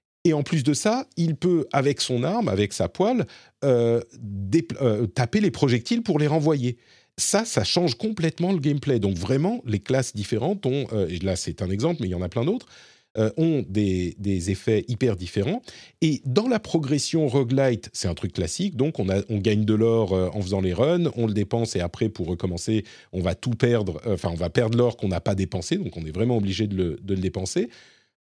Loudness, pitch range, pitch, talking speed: -24 LUFS, 100-145 Hz, 115 Hz, 225 wpm